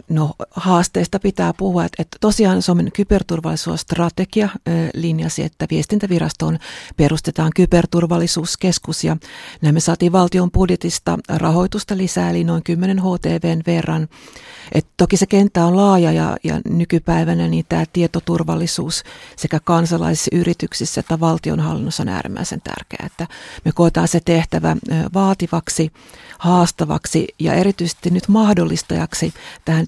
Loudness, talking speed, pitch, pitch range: -17 LUFS, 120 wpm, 170 Hz, 160-180 Hz